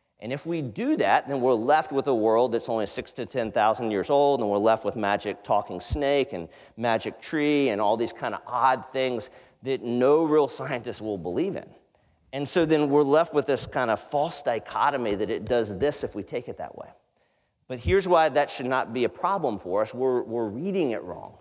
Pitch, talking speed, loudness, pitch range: 130 Hz, 220 wpm, -25 LUFS, 115-145 Hz